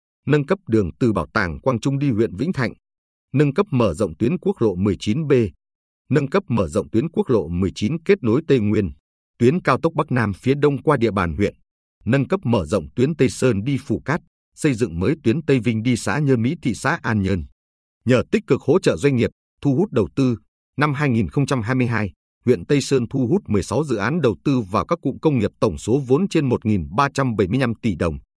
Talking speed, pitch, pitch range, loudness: 215 wpm, 125 Hz, 100-140 Hz, -20 LUFS